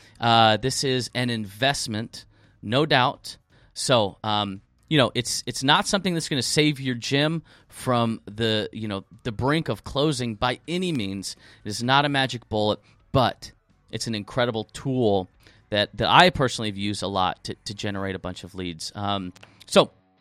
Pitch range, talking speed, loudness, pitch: 100-130 Hz, 175 wpm, -24 LUFS, 110 Hz